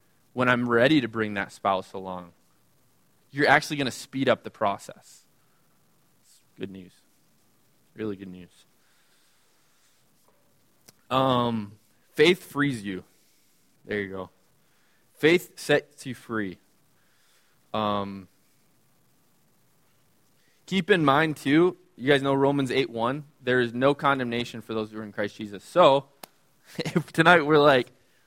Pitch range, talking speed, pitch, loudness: 105-145 Hz, 125 wpm, 120 Hz, -24 LUFS